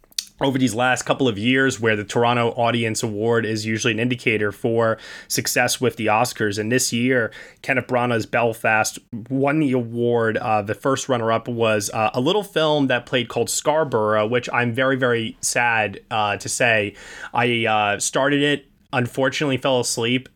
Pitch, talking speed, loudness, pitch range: 120 Hz, 170 wpm, -20 LUFS, 115-130 Hz